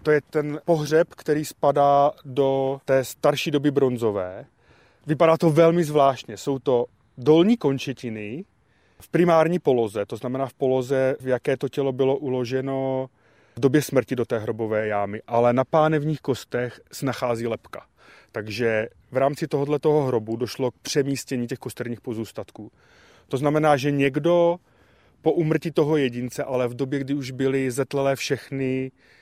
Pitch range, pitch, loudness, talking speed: 125-145 Hz, 135 Hz, -23 LUFS, 150 wpm